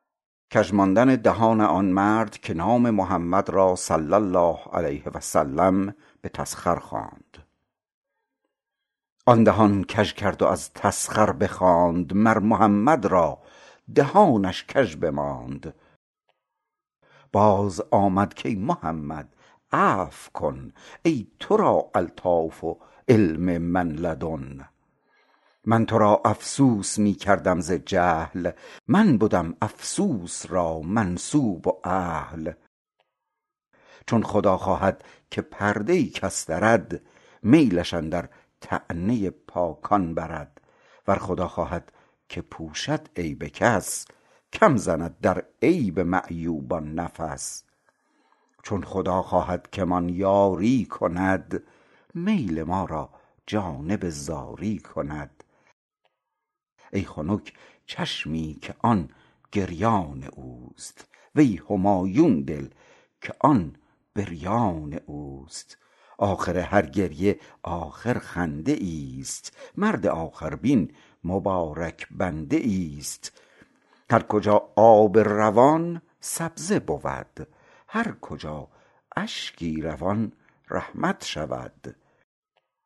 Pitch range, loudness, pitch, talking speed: 80-105 Hz, -24 LUFS, 90 Hz, 95 wpm